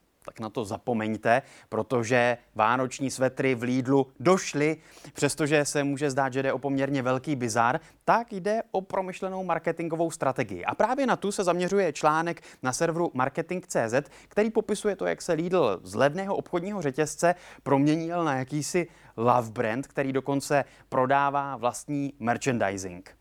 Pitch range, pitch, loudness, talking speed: 130-170 Hz, 145 Hz, -27 LUFS, 145 wpm